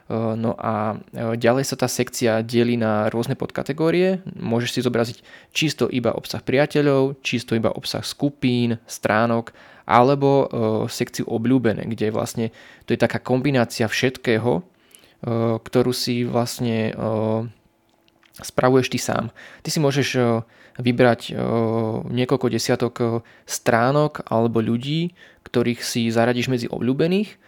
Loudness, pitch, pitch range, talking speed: -21 LUFS, 120 Hz, 115-130 Hz, 115 wpm